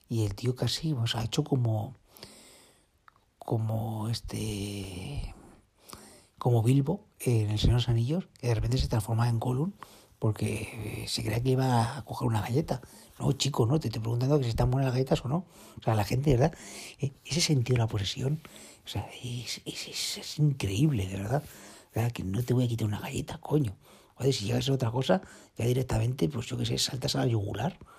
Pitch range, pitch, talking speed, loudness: 110-135 Hz, 120 Hz, 205 wpm, -30 LUFS